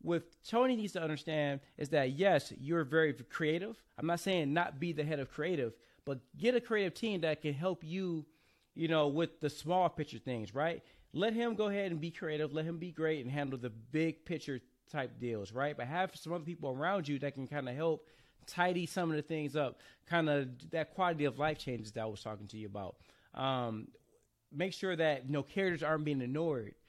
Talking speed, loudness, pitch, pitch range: 220 wpm, -36 LUFS, 155 Hz, 135-170 Hz